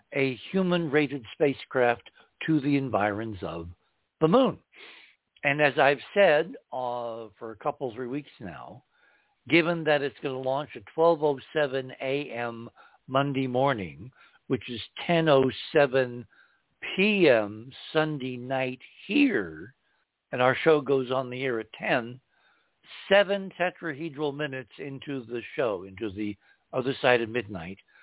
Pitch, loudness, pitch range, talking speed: 135 Hz, -27 LUFS, 120-150 Hz, 125 wpm